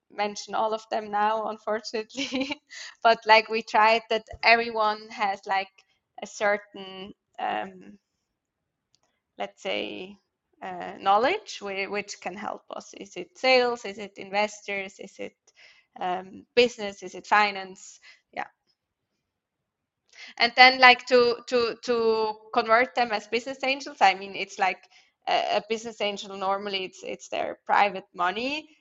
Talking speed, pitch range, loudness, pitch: 135 wpm, 195-240 Hz, -24 LUFS, 215 Hz